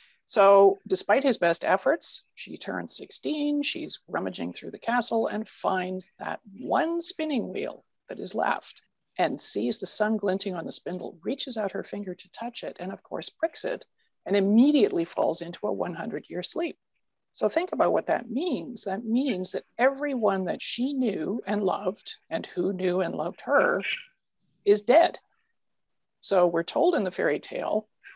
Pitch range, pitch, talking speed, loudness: 190-290 Hz, 220 Hz, 170 wpm, -26 LUFS